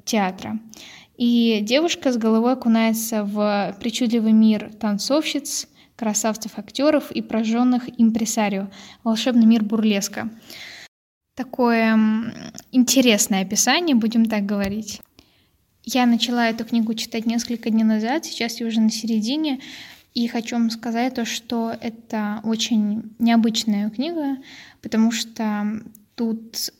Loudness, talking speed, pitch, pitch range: -21 LUFS, 110 wpm, 230 Hz, 220-240 Hz